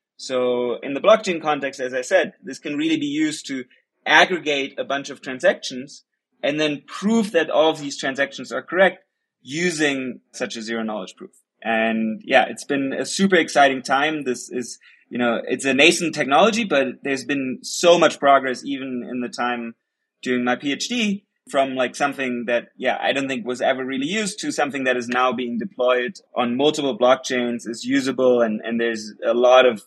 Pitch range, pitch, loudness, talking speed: 125-150 Hz, 135 Hz, -20 LUFS, 190 wpm